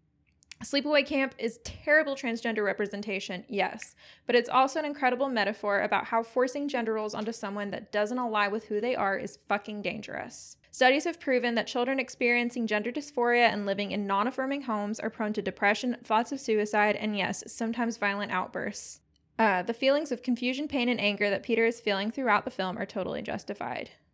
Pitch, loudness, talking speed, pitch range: 225 Hz, -29 LUFS, 185 wpm, 205-250 Hz